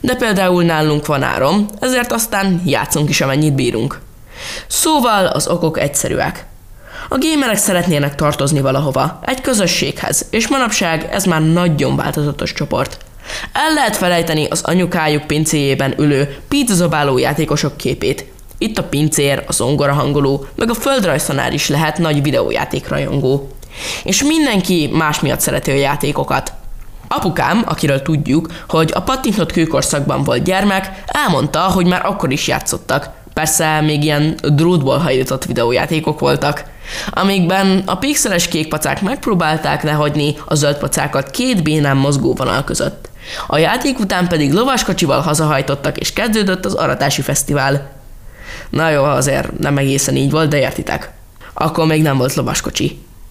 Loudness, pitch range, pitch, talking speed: -15 LUFS, 145-185 Hz, 155 Hz, 135 wpm